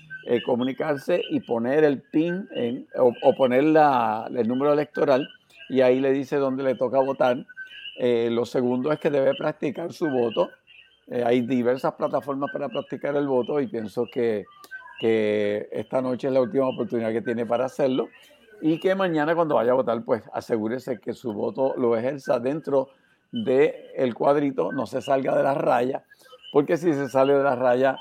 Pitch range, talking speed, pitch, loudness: 125-160 Hz, 180 wpm, 135 Hz, -24 LUFS